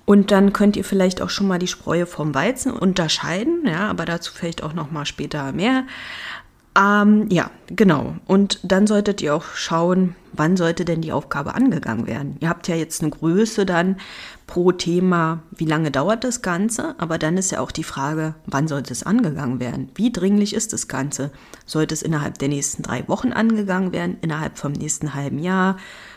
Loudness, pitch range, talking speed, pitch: -20 LUFS, 155-200 Hz, 190 wpm, 175 Hz